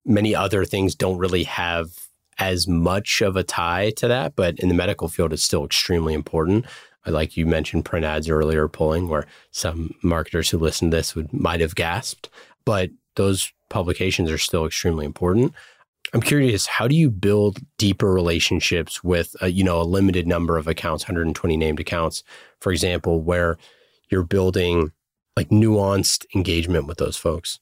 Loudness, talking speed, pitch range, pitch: -21 LUFS, 170 wpm, 80-95 Hz, 90 Hz